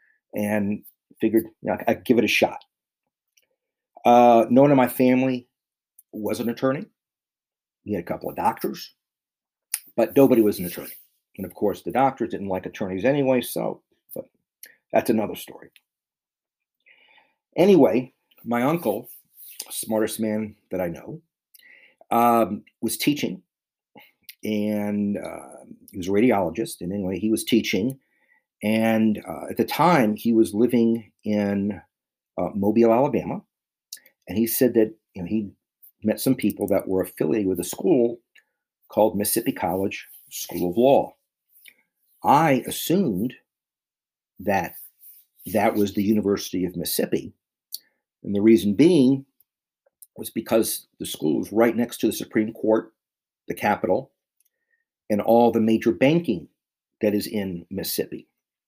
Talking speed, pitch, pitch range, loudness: 135 wpm, 110 Hz, 100-120 Hz, -22 LUFS